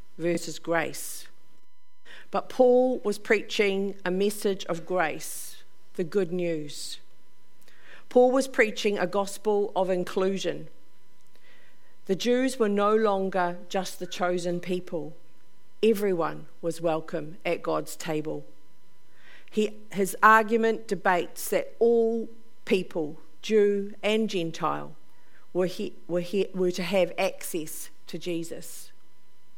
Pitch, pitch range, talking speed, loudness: 185 Hz, 170-210 Hz, 100 wpm, -27 LUFS